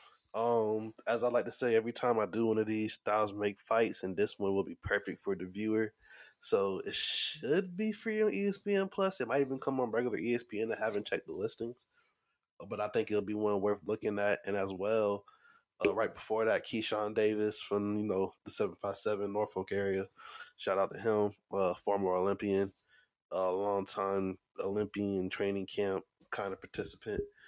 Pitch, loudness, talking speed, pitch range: 105 Hz, -34 LUFS, 190 wpm, 100-135 Hz